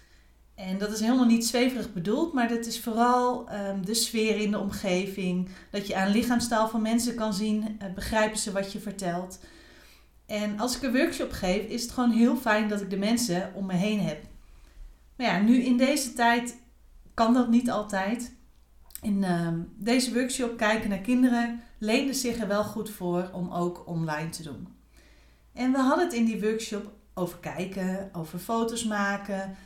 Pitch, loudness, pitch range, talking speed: 215 Hz, -27 LUFS, 195-235 Hz, 180 wpm